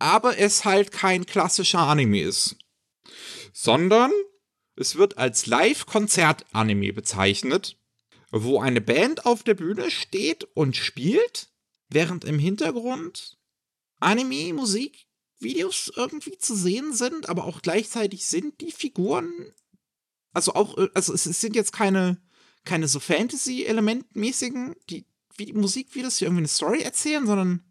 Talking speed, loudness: 120 wpm, -23 LUFS